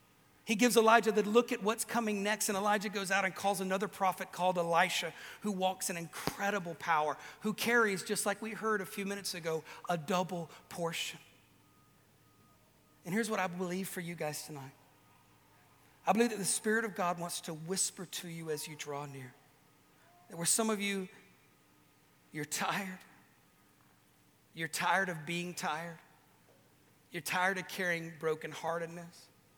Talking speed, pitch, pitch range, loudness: 160 wpm, 180 Hz, 160-200 Hz, -34 LUFS